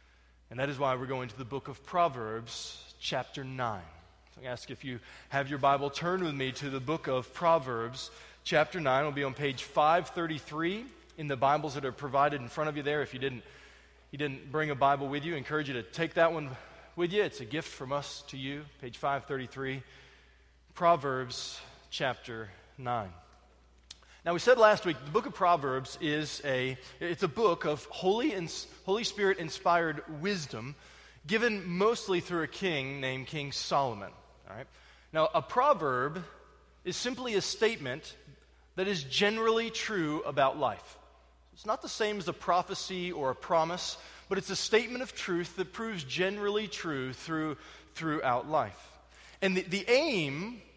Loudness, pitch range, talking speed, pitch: -32 LUFS, 130-180 Hz, 180 wpm, 150 Hz